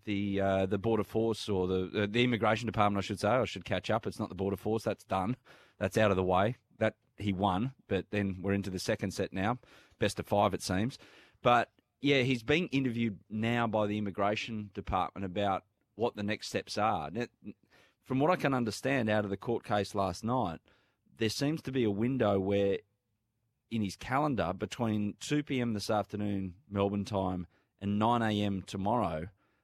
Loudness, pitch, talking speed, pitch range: -32 LUFS, 105 Hz, 190 wpm, 100-115 Hz